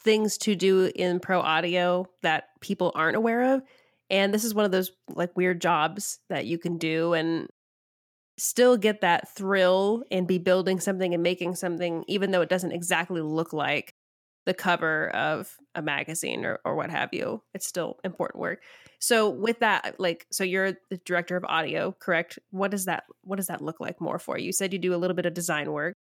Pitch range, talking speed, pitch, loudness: 170-195 Hz, 205 wpm, 180 Hz, -26 LUFS